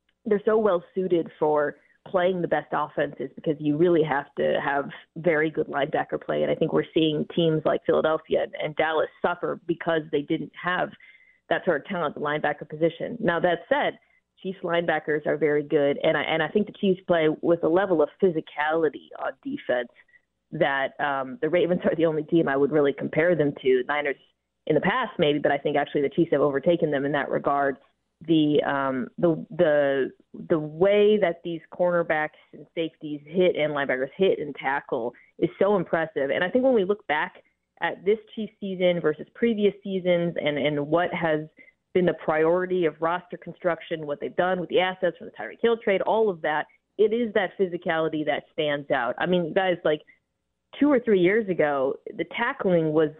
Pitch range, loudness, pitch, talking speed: 150-190 Hz, -25 LUFS, 170 Hz, 195 wpm